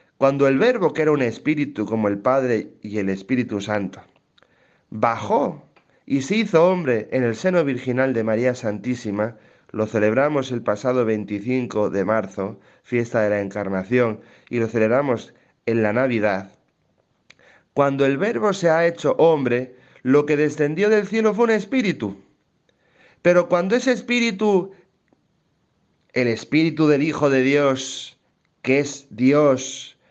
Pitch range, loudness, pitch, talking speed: 110-160 Hz, -21 LUFS, 130 Hz, 140 wpm